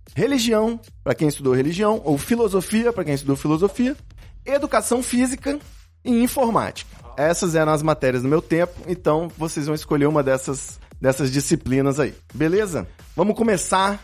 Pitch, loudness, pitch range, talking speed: 165 Hz, -21 LUFS, 145-220 Hz, 145 wpm